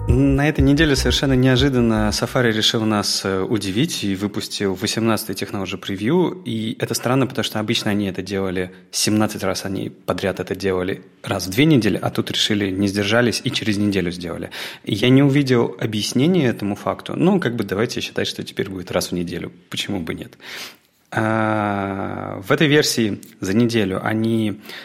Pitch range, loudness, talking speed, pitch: 95-120 Hz, -20 LUFS, 165 wpm, 105 Hz